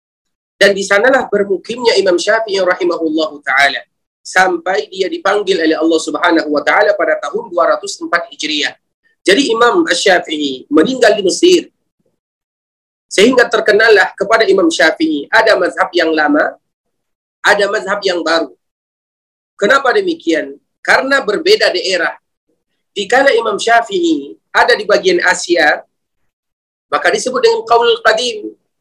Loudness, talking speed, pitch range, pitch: -12 LUFS, 115 wpm, 170-255 Hz, 200 Hz